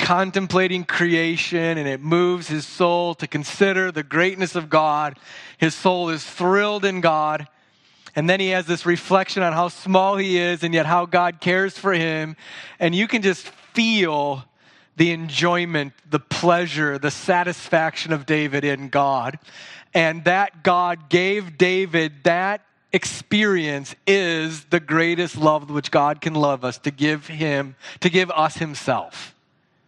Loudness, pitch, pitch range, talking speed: -20 LUFS, 170 Hz, 150-180 Hz, 150 wpm